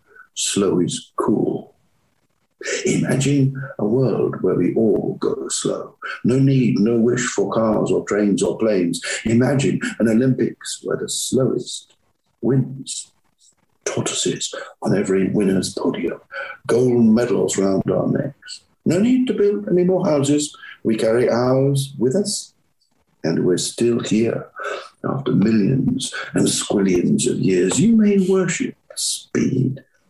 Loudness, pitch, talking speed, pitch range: -19 LUFS, 135 Hz, 130 wpm, 115-190 Hz